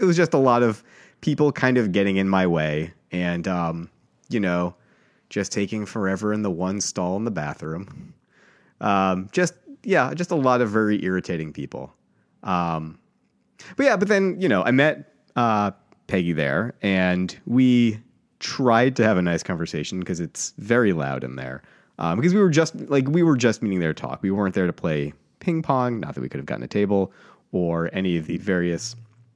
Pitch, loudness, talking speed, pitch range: 100 Hz, -23 LUFS, 195 wpm, 90-125 Hz